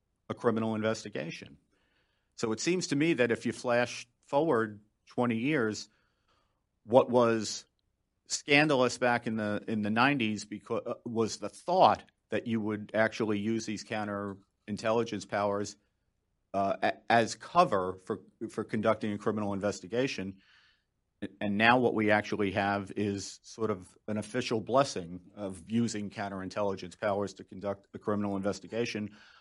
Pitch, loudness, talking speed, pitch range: 105 Hz, -31 LUFS, 140 wpm, 100-115 Hz